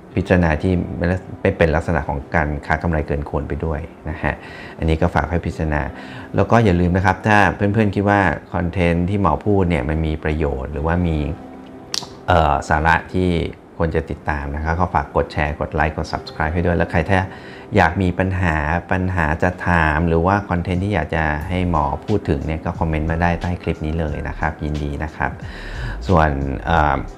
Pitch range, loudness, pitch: 75-90 Hz, -19 LUFS, 85 Hz